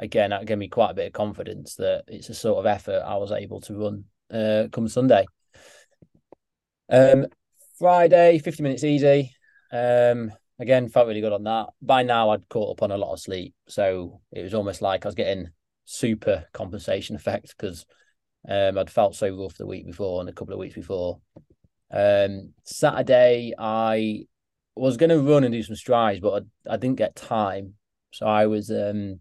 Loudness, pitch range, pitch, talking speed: -23 LUFS, 100-130 Hz, 110 Hz, 190 wpm